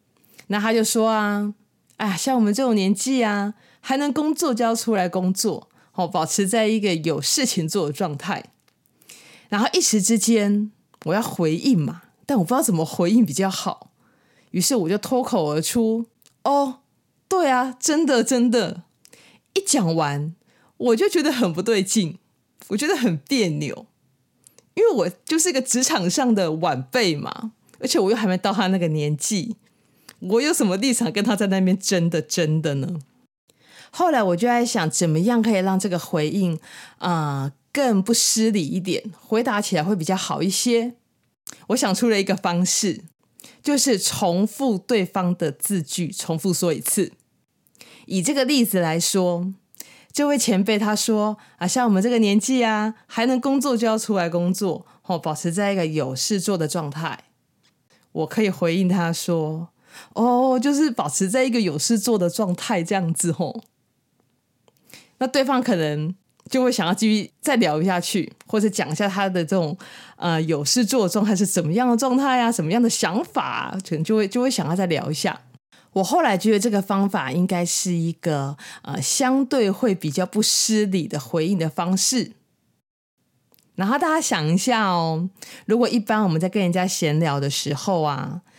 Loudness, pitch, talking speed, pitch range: -21 LUFS, 200 Hz, 255 characters per minute, 175-235 Hz